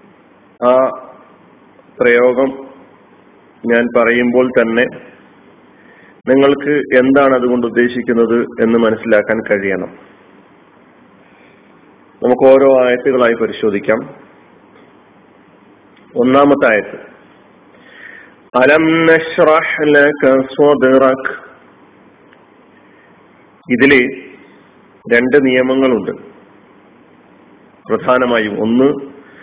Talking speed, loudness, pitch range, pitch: 50 wpm, -12 LUFS, 115-135 Hz, 125 Hz